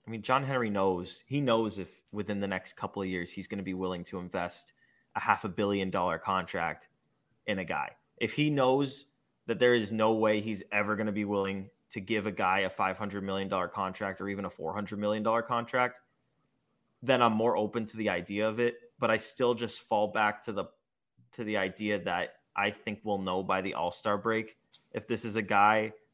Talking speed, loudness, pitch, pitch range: 215 wpm, -31 LUFS, 105 Hz, 95-115 Hz